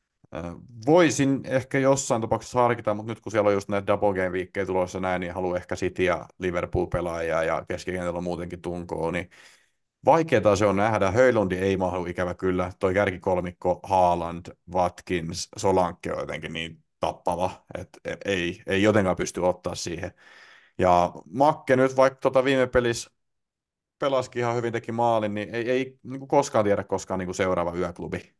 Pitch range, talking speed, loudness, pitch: 90-120 Hz, 160 wpm, -25 LUFS, 95 Hz